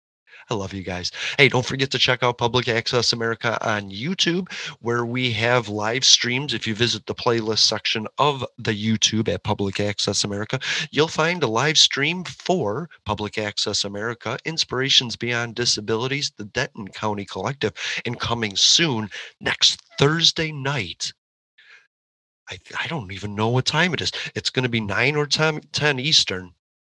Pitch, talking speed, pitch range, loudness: 120 Hz, 165 wpm, 105-135 Hz, -21 LUFS